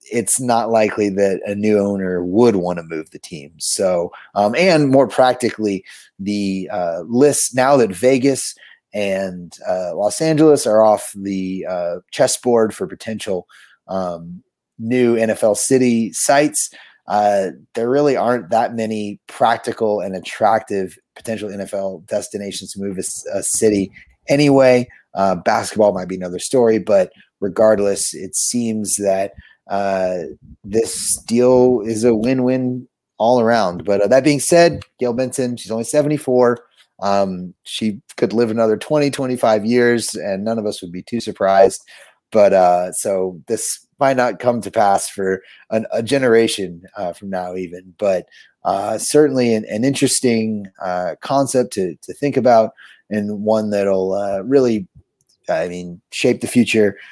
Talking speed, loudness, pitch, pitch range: 150 wpm, -17 LUFS, 110 Hz, 95-125 Hz